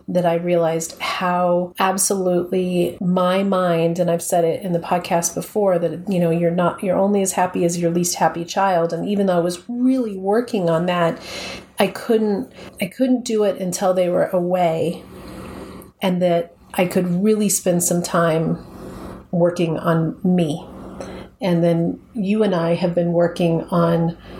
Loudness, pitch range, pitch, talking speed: -19 LUFS, 170-190 Hz, 180 Hz, 165 wpm